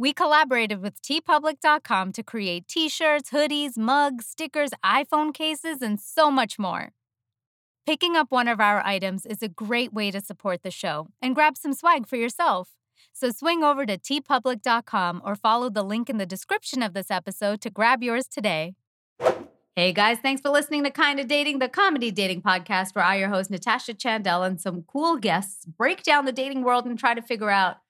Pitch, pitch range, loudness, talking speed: 235 Hz, 195-290 Hz, -24 LUFS, 185 wpm